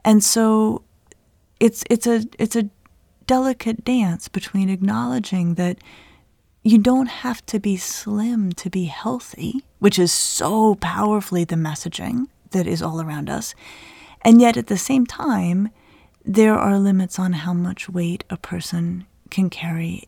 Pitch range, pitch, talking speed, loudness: 180-230 Hz, 205 Hz, 145 wpm, -20 LUFS